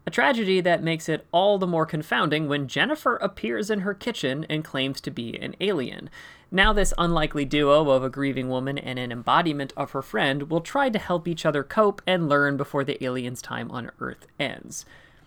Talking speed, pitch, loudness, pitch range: 200 wpm, 155 Hz, -24 LUFS, 140-185 Hz